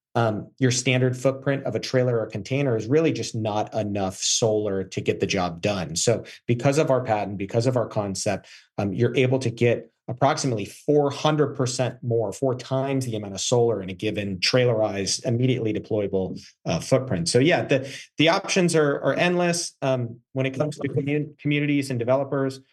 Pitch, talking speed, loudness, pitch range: 125 Hz, 185 wpm, -24 LUFS, 110-140 Hz